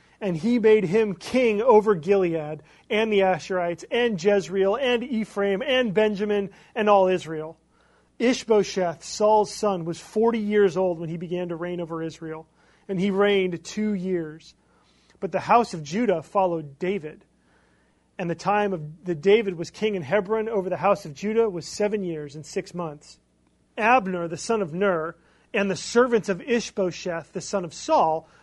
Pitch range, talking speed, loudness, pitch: 170-215 Hz, 165 wpm, -24 LUFS, 190 Hz